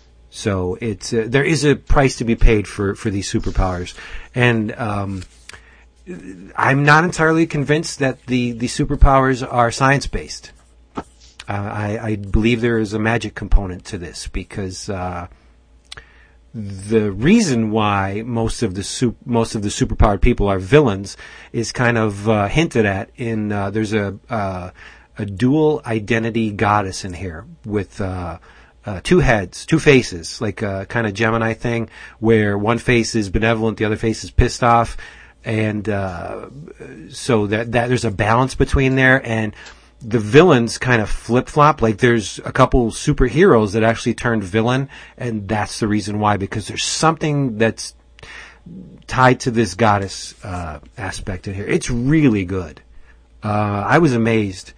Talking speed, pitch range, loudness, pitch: 160 wpm, 100-120 Hz, -18 LUFS, 110 Hz